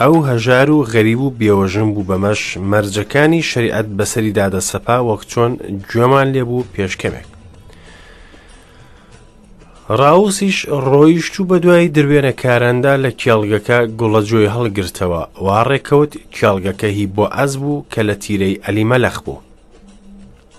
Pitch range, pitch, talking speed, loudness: 100-140 Hz, 115 Hz, 110 wpm, -14 LUFS